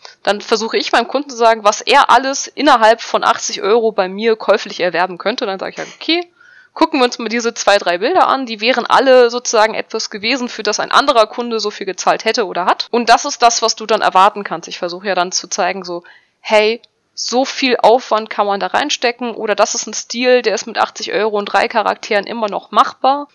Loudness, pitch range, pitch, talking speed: -14 LUFS, 205-250 Hz, 225 Hz, 230 wpm